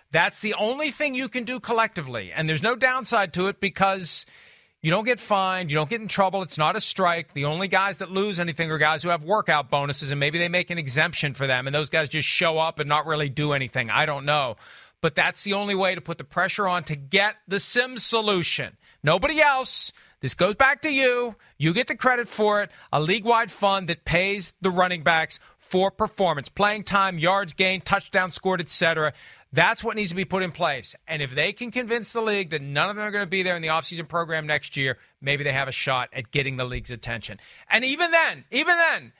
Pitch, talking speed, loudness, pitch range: 180 Hz, 235 wpm, -23 LUFS, 155-210 Hz